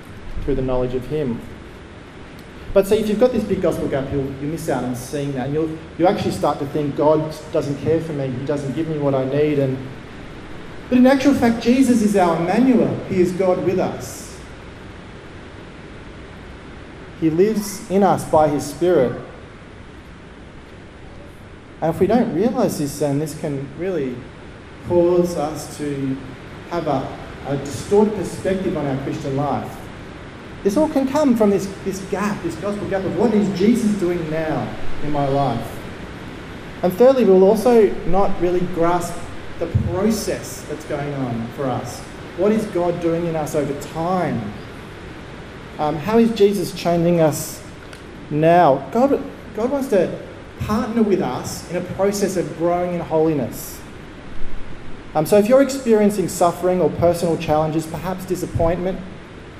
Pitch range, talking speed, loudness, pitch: 140-195 Hz, 160 wpm, -19 LUFS, 165 Hz